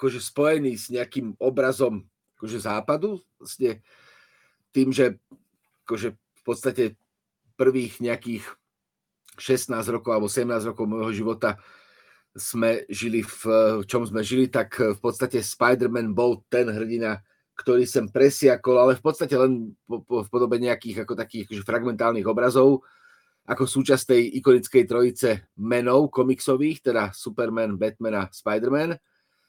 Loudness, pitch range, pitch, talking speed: -23 LUFS, 110-130 Hz, 120 Hz, 125 wpm